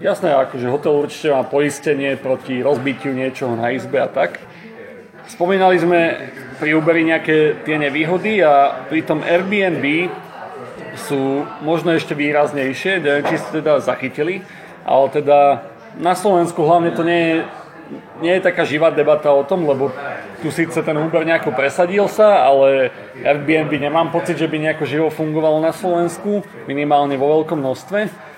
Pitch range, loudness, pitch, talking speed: 140-170 Hz, -17 LUFS, 155 Hz, 150 wpm